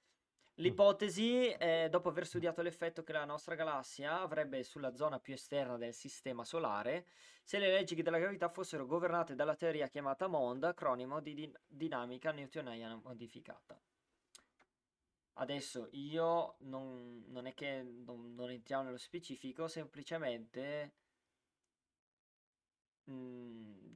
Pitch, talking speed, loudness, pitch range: 145 Hz, 120 wpm, -40 LUFS, 125-170 Hz